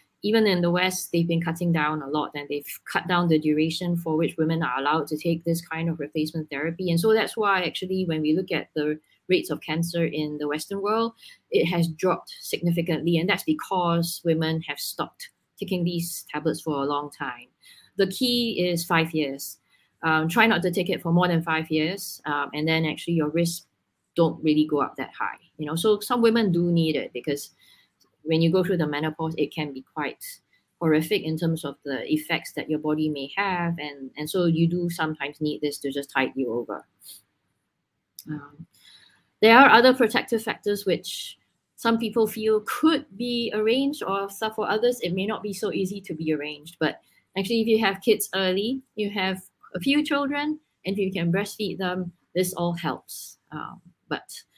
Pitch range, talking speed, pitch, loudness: 155-200 Hz, 200 wpm, 170 Hz, -25 LUFS